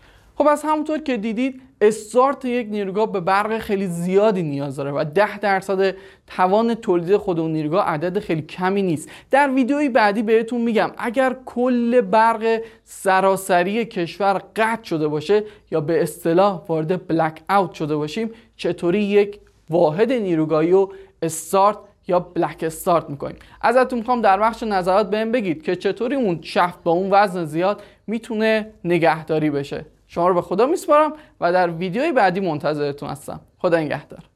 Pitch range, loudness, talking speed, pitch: 175-225 Hz, -20 LUFS, 155 wpm, 195 Hz